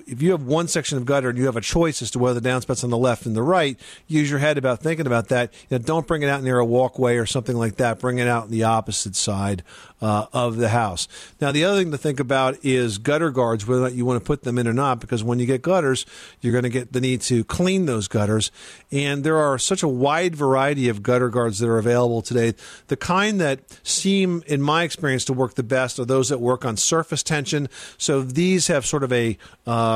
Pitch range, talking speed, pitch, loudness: 120-150 Hz, 255 wpm, 130 Hz, -21 LUFS